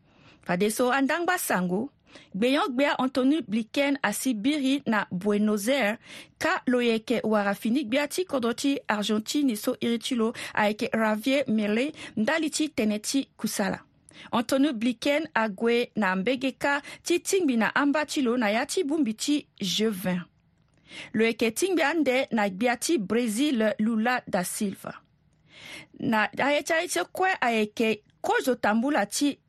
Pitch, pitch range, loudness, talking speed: 245 Hz, 215-285 Hz, -26 LUFS, 155 wpm